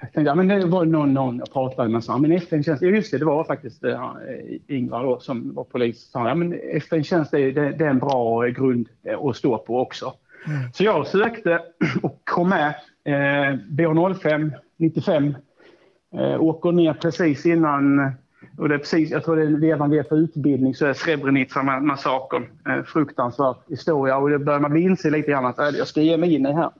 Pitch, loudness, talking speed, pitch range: 150 Hz, -21 LUFS, 190 wpm, 135-165 Hz